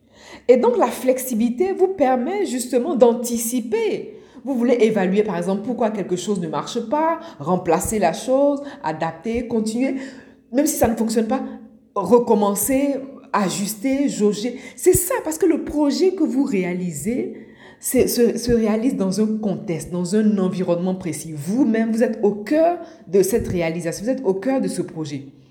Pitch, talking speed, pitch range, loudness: 235 Hz, 160 wpm, 195-270 Hz, -20 LUFS